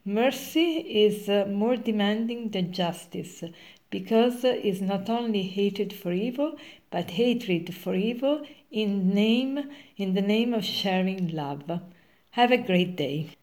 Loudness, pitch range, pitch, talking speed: -27 LUFS, 185-240 Hz, 205 Hz, 140 wpm